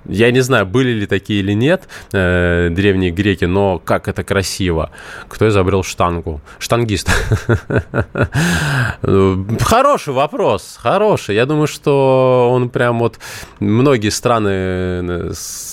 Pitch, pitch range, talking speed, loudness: 100 Hz, 95-120 Hz, 110 wpm, -15 LUFS